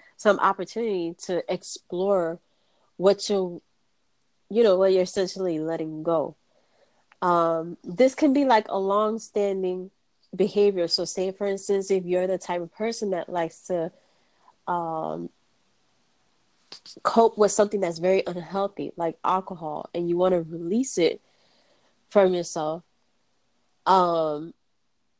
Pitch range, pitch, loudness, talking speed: 170-200 Hz, 185 Hz, -25 LUFS, 125 wpm